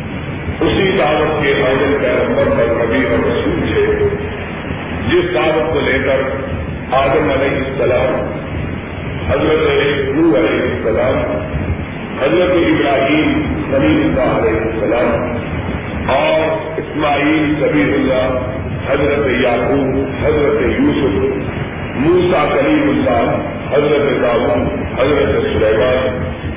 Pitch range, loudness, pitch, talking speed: 90-145 Hz, -15 LUFS, 130 Hz, 90 wpm